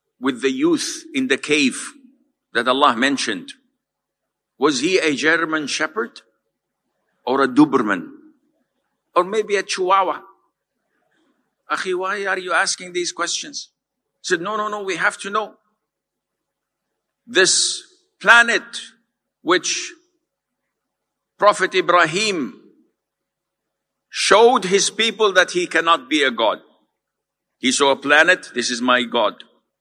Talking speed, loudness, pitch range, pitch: 120 wpm, -18 LUFS, 180-280 Hz, 215 Hz